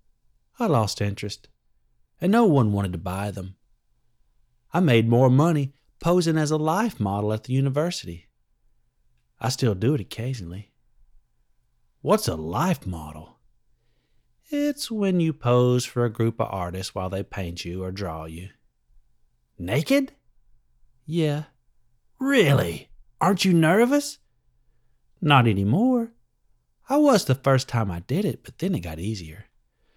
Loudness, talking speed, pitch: -23 LUFS, 135 wpm, 120 Hz